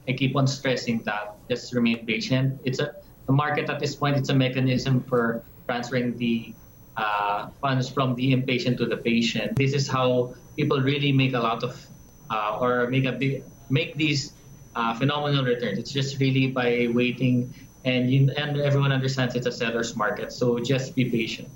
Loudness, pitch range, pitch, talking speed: -25 LUFS, 120-135 Hz, 130 Hz, 185 wpm